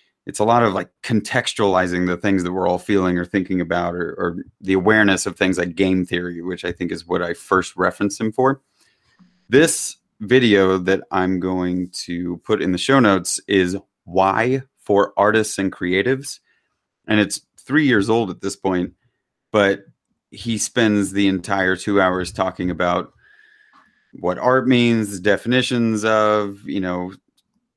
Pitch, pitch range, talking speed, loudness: 95 Hz, 90-110 Hz, 160 wpm, -19 LUFS